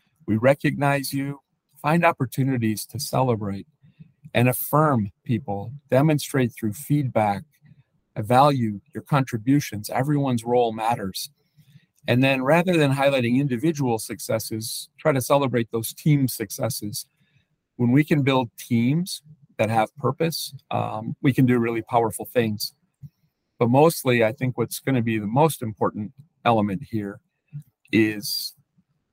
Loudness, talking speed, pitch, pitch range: -23 LUFS, 125 wpm, 135 Hz, 115-150 Hz